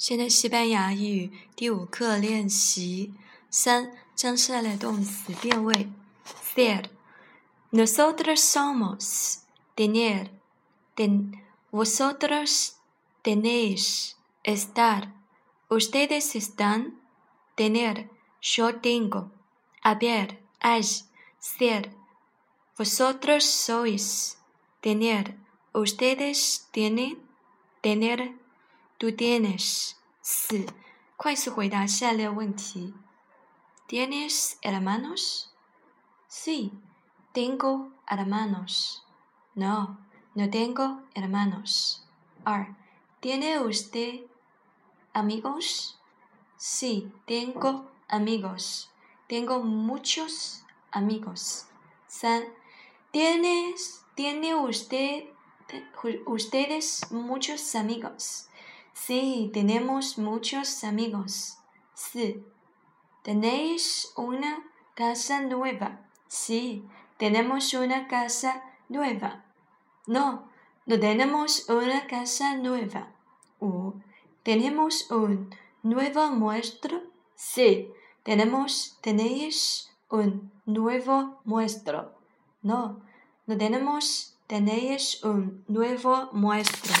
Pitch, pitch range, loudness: 230 Hz, 210-260 Hz, -27 LUFS